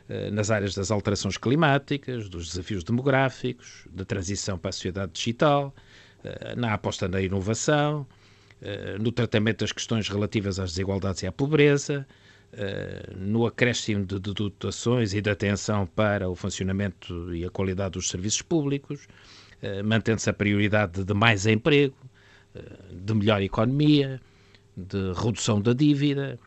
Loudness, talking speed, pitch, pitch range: -26 LUFS, 130 wpm, 105 Hz, 100-120 Hz